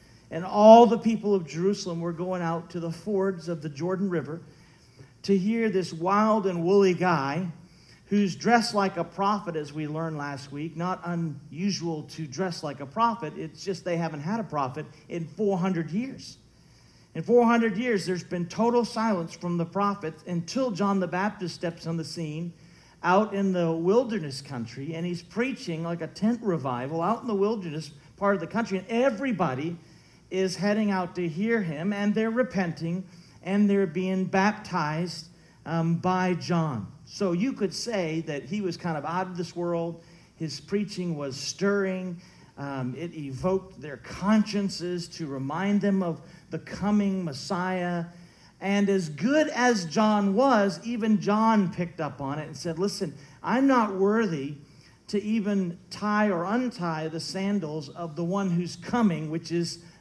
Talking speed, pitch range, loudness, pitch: 165 wpm, 165-200 Hz, -27 LUFS, 180 Hz